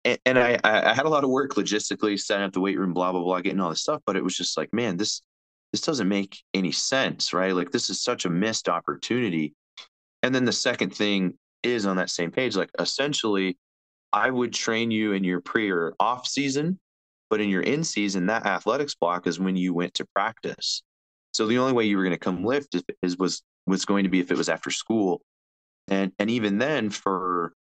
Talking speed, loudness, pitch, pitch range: 220 wpm, -25 LUFS, 95 Hz, 90-110 Hz